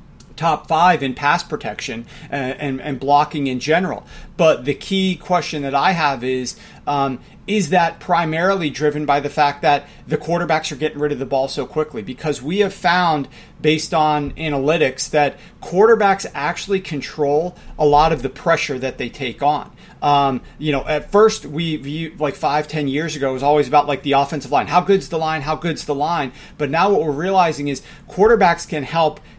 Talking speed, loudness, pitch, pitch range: 195 wpm, -18 LUFS, 150 Hz, 145-170 Hz